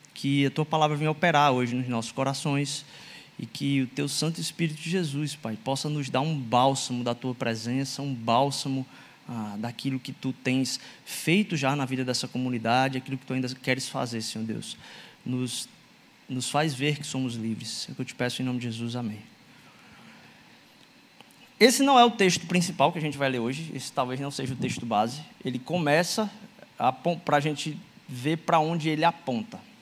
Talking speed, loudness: 195 wpm, -27 LUFS